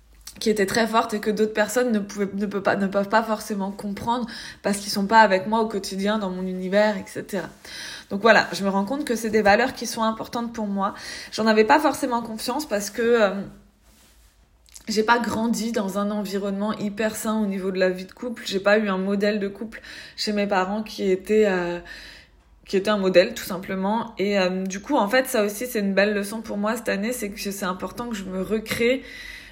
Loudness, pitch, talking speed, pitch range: -23 LUFS, 210 Hz, 225 wpm, 195-225 Hz